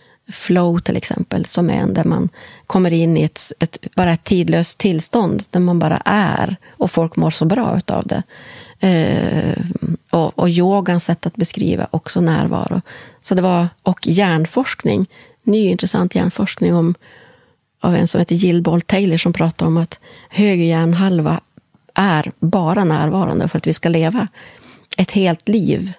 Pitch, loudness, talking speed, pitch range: 175 Hz, -17 LUFS, 160 wpm, 165-195 Hz